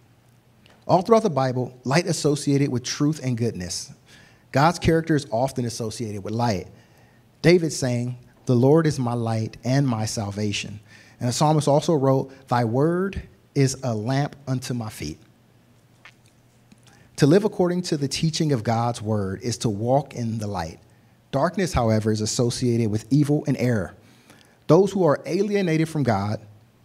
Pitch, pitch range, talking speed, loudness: 125 Hz, 115-145 Hz, 155 wpm, -23 LUFS